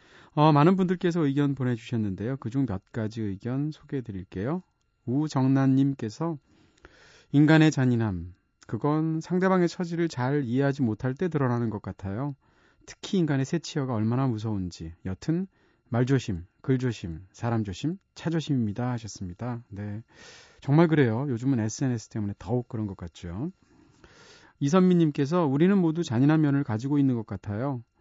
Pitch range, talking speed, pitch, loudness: 110-150 Hz, 330 characters per minute, 130 Hz, -27 LUFS